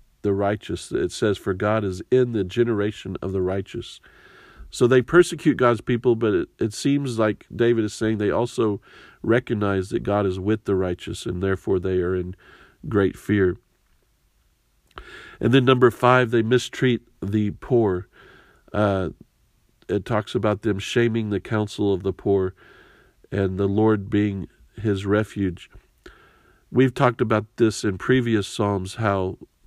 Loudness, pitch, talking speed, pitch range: -22 LUFS, 105 Hz, 150 wpm, 95-120 Hz